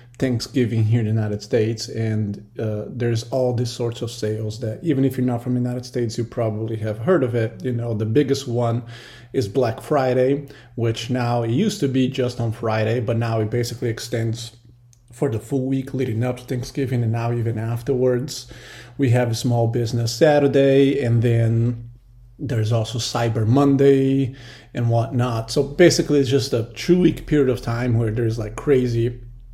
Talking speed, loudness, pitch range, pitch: 185 wpm, -21 LUFS, 115-130 Hz, 120 Hz